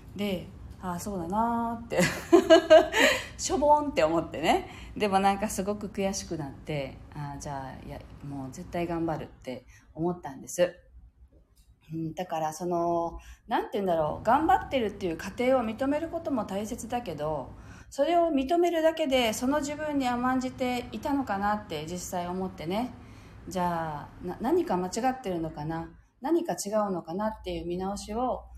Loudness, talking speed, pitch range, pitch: -28 LUFS, 315 characters per minute, 165-255 Hz, 195 Hz